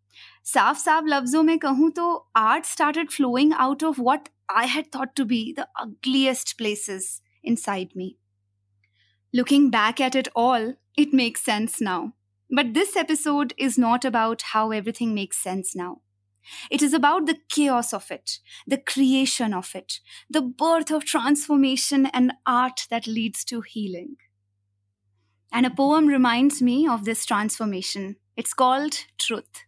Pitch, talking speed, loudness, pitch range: 250 Hz, 145 wpm, -23 LUFS, 210-285 Hz